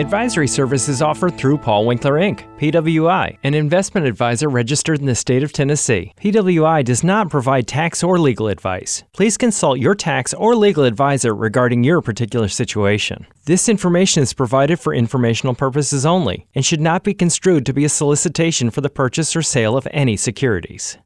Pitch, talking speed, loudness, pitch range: 140 Hz, 175 wpm, -16 LUFS, 120-165 Hz